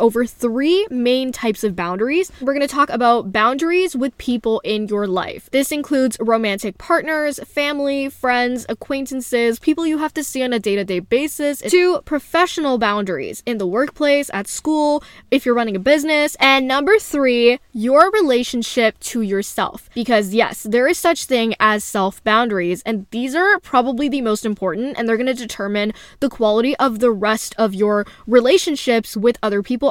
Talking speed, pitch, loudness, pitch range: 170 wpm, 245 Hz, -18 LUFS, 220-285 Hz